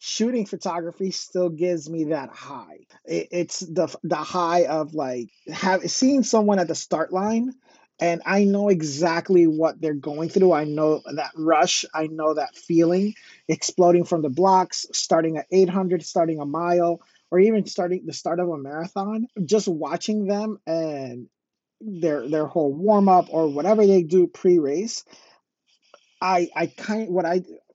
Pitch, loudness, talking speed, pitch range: 175 Hz, -22 LUFS, 165 wpm, 160-195 Hz